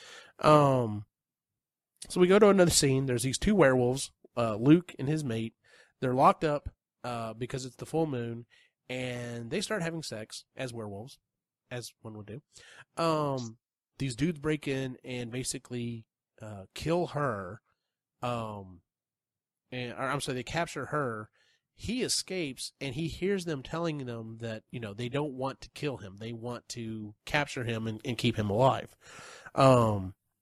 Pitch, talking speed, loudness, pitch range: 125 Hz, 160 wpm, -30 LUFS, 115-150 Hz